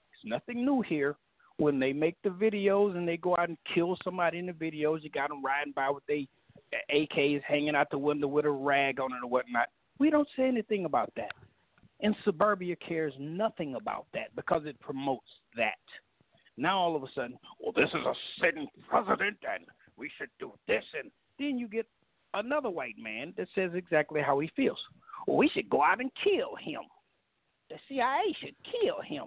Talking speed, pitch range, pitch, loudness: 195 wpm, 145-210 Hz, 170 Hz, -31 LUFS